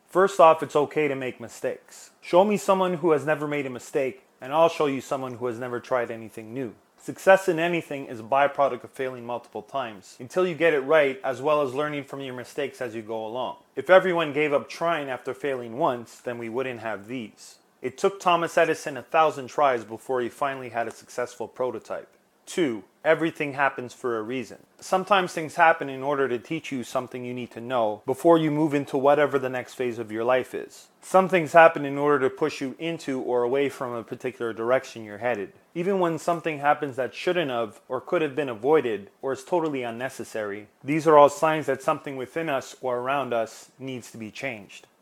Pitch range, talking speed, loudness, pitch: 125-160 Hz, 210 wpm, -25 LUFS, 135 Hz